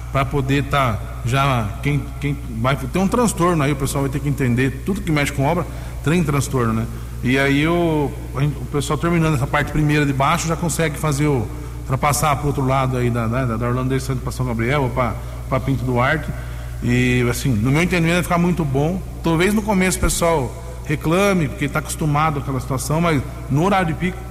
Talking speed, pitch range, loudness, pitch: 210 wpm, 130-160 Hz, -19 LUFS, 140 Hz